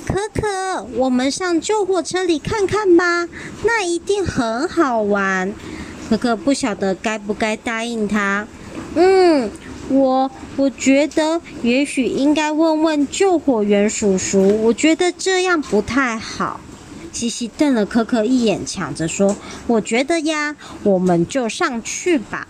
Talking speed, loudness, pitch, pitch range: 195 characters per minute, -18 LUFS, 270 Hz, 220-330 Hz